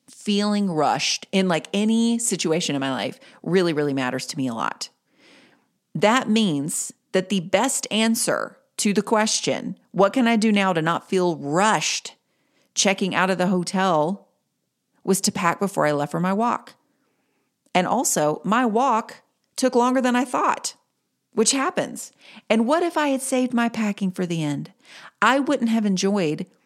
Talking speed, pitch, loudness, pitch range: 165 wpm, 205 Hz, -22 LUFS, 180-240 Hz